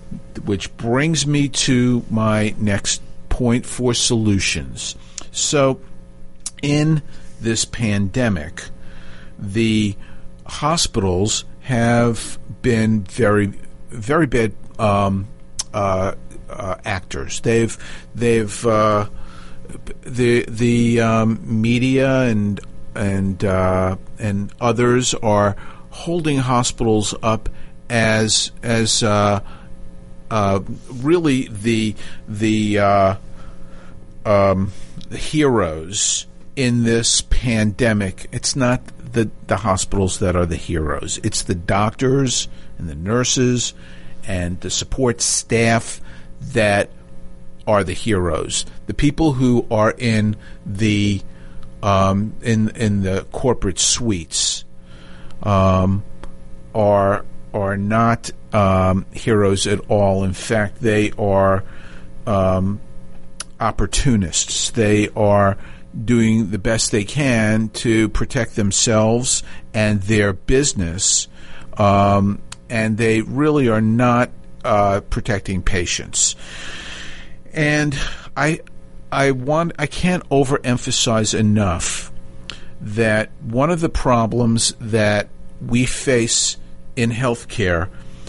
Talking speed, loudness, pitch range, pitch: 95 wpm, -18 LUFS, 85-115 Hz, 105 Hz